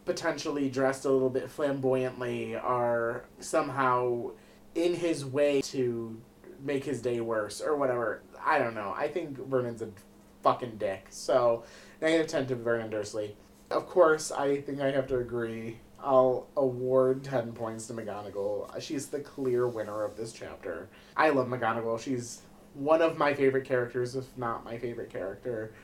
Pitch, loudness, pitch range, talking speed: 125 Hz, -30 LUFS, 115-140 Hz, 160 wpm